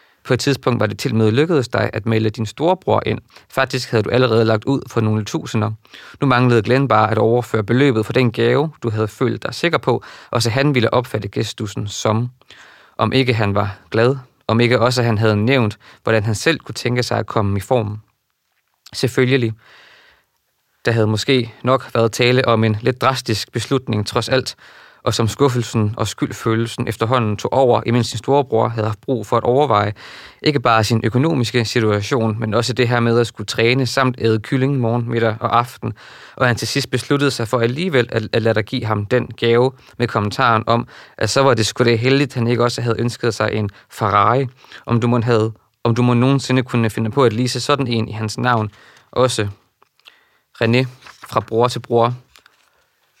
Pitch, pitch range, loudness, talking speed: 120 Hz, 110-130 Hz, -18 LUFS, 200 wpm